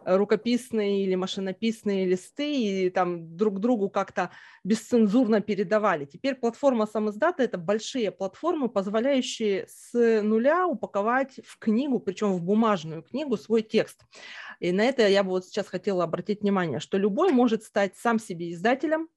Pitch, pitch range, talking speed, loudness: 215 Hz, 195-235 Hz, 145 wpm, -26 LUFS